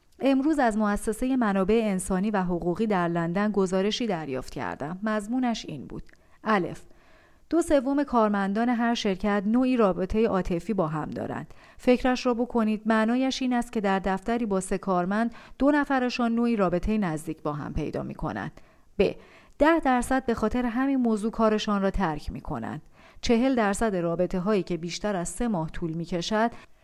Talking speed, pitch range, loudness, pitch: 165 wpm, 190-240 Hz, -26 LUFS, 215 Hz